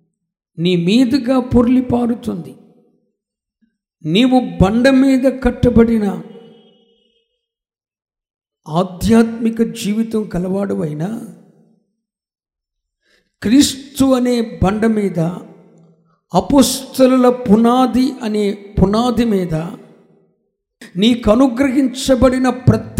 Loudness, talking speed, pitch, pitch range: -15 LUFS, 55 wpm, 225 Hz, 190-250 Hz